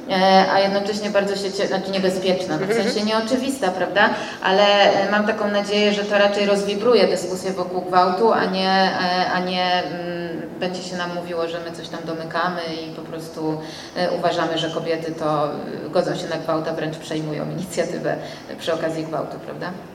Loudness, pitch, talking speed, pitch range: -21 LUFS, 180 Hz, 155 wpm, 165-200 Hz